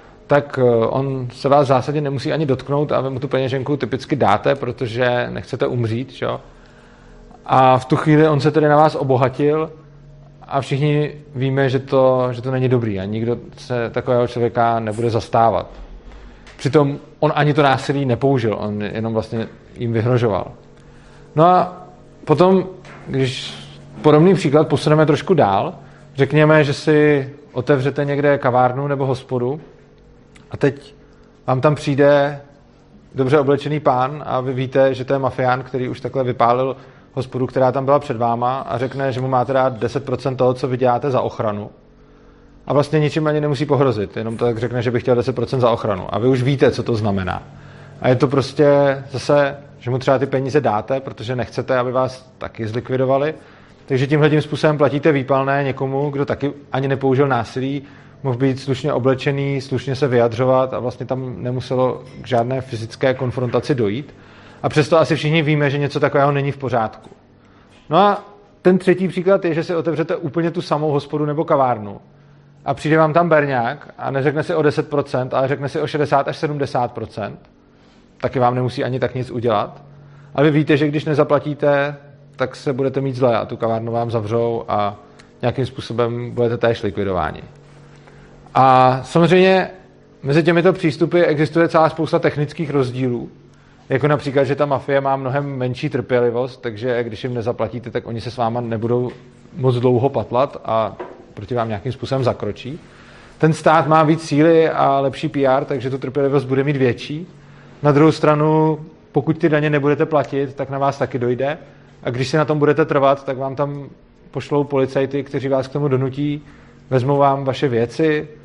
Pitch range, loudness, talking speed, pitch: 125-150 Hz, -18 LUFS, 170 wpm, 135 Hz